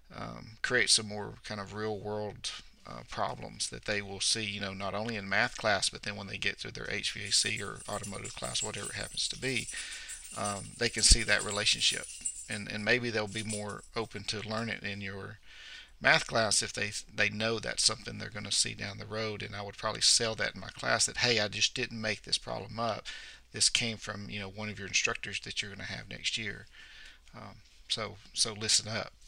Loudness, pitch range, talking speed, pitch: -31 LUFS, 100-110 Hz, 220 wpm, 105 Hz